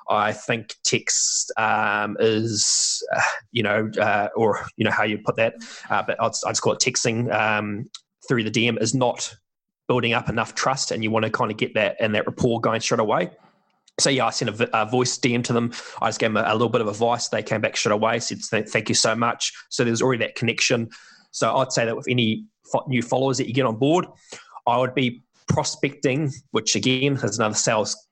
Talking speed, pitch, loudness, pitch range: 225 wpm, 120 Hz, -22 LUFS, 110-130 Hz